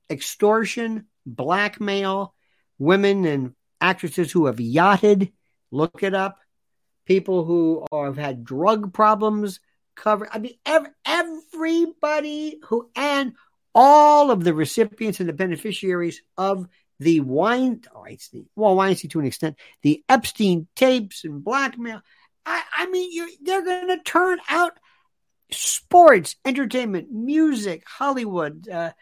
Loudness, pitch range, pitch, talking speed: -21 LUFS, 175-275 Hz, 210 Hz, 125 wpm